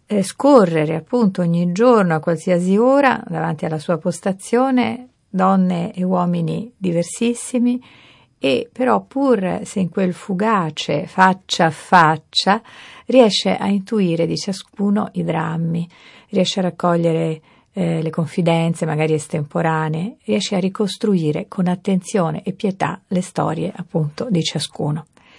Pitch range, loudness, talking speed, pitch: 165-210 Hz, -18 LUFS, 125 wpm, 185 Hz